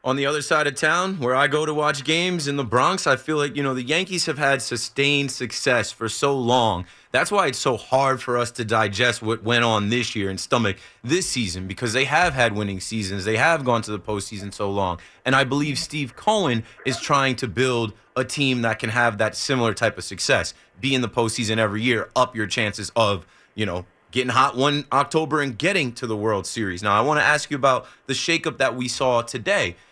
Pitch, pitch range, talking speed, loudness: 125 Hz, 110-140 Hz, 230 wpm, -22 LUFS